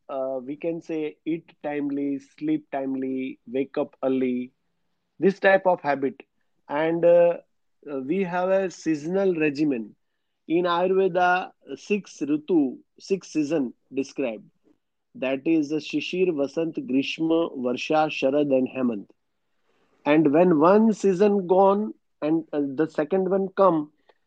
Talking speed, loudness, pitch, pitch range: 125 wpm, -24 LUFS, 160 Hz, 140-190 Hz